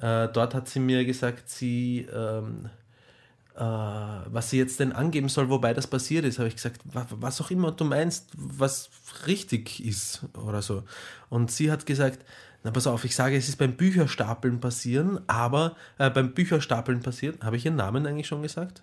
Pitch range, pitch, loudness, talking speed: 120-145 Hz, 130 Hz, -27 LUFS, 180 wpm